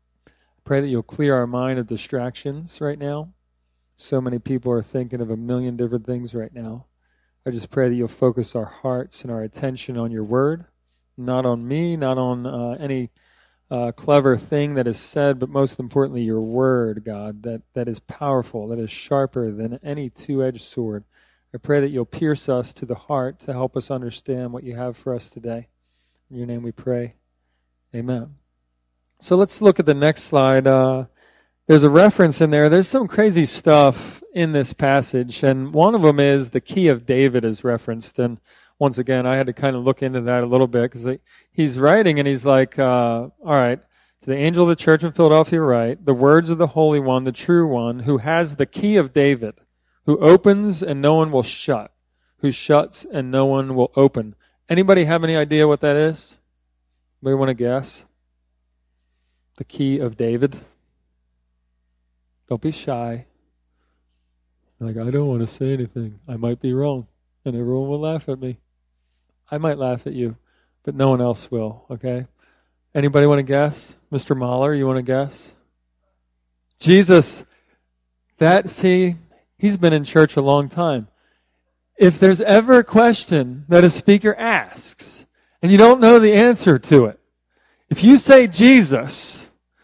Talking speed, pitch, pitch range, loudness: 180 wpm, 130 Hz, 115-150 Hz, -17 LUFS